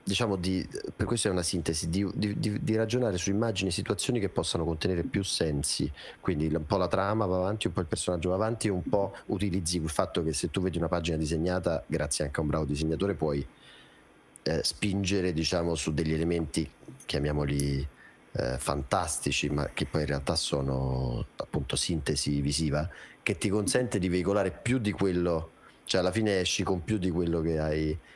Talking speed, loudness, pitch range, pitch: 190 wpm, -30 LUFS, 75-100 Hz, 85 Hz